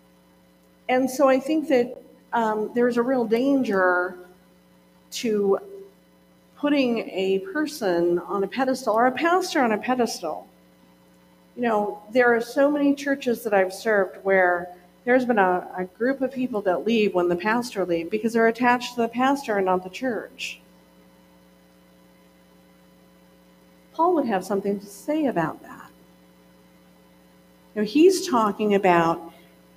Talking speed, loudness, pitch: 140 wpm, -23 LUFS, 195 Hz